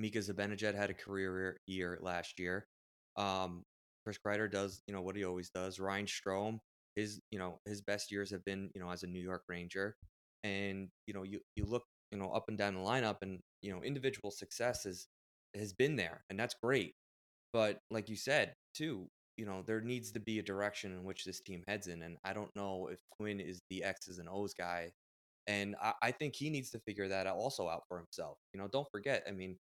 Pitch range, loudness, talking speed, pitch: 90-105 Hz, -41 LUFS, 220 wpm, 95 Hz